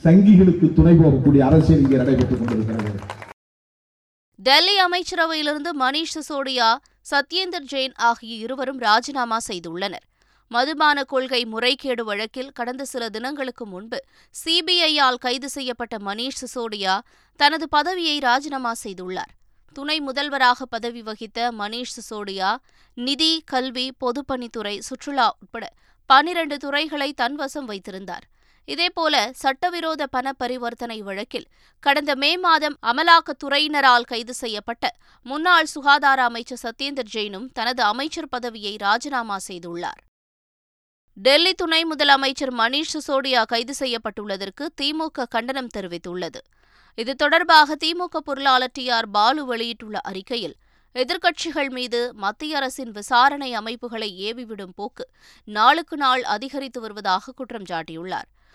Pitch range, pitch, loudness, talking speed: 220-285 Hz, 255 Hz, -21 LUFS, 100 wpm